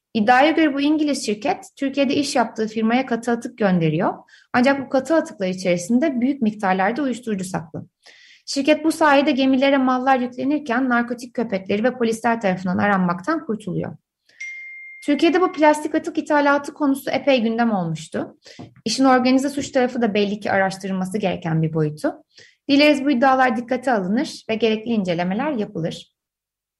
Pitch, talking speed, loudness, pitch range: 255 Hz, 140 wpm, -20 LUFS, 210-290 Hz